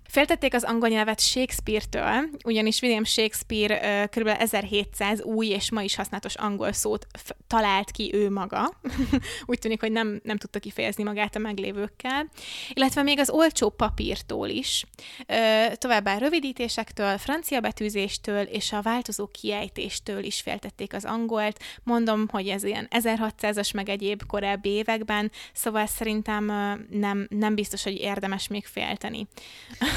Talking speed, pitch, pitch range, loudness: 140 wpm, 215 Hz, 205-230 Hz, -26 LUFS